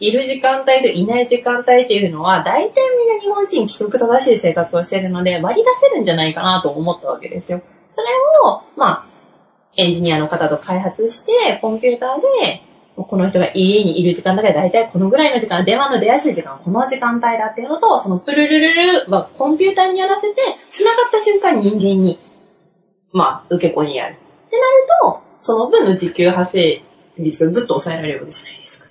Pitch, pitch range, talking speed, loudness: 220 Hz, 180-275 Hz, 420 characters per minute, -15 LUFS